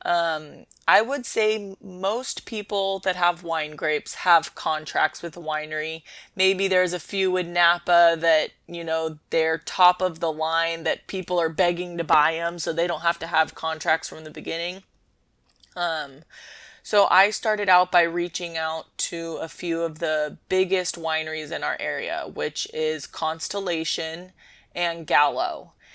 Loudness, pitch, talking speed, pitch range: -24 LUFS, 170 Hz, 160 wpm, 160-185 Hz